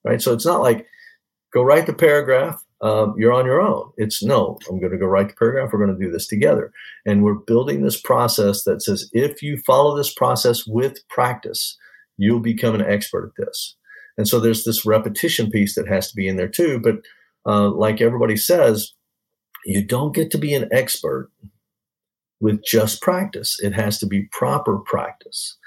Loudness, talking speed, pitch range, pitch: -19 LUFS, 195 wpm, 105-130 Hz, 110 Hz